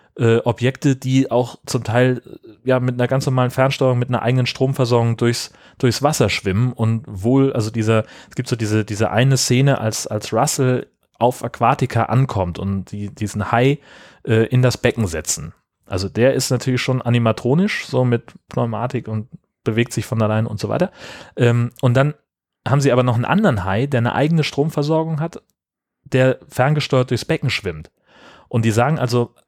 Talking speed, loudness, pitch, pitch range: 175 wpm, -19 LUFS, 125 Hz, 115-130 Hz